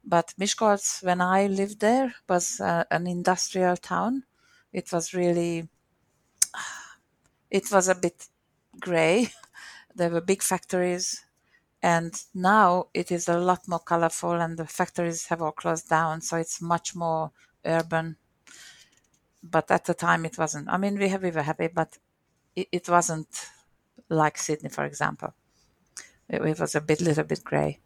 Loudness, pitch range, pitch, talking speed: -26 LUFS, 160-185 Hz, 170 Hz, 150 wpm